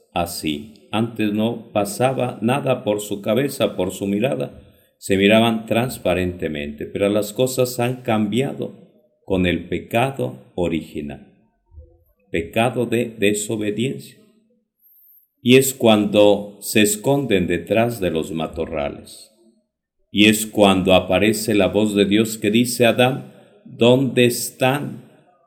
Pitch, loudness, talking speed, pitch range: 110 Hz, -19 LUFS, 115 wpm, 95-120 Hz